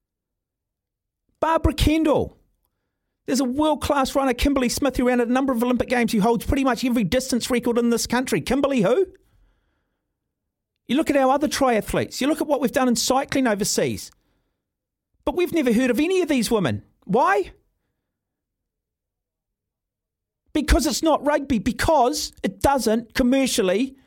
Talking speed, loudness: 155 wpm, -21 LUFS